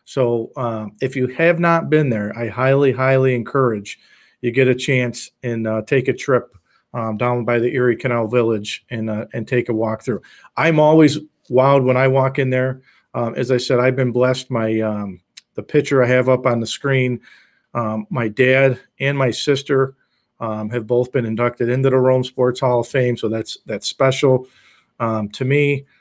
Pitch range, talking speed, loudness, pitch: 115-135 Hz, 195 wpm, -18 LUFS, 125 Hz